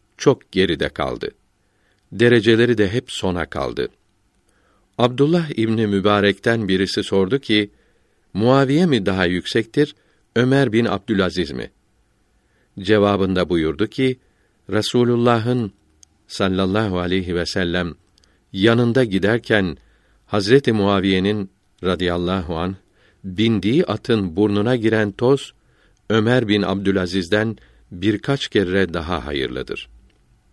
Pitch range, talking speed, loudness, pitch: 95-115 Hz, 95 wpm, -19 LUFS, 105 Hz